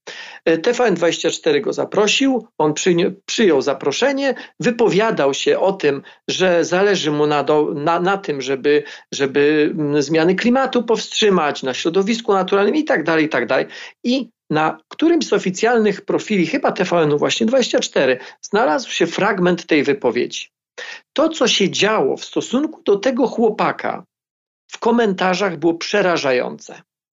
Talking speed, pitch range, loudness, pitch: 120 wpm, 160-245 Hz, -17 LUFS, 195 Hz